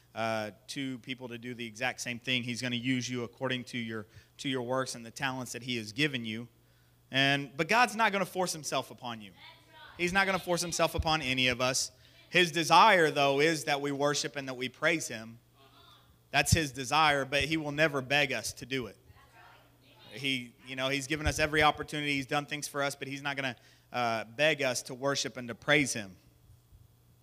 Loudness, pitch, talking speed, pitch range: -30 LUFS, 130 Hz, 220 wpm, 120-145 Hz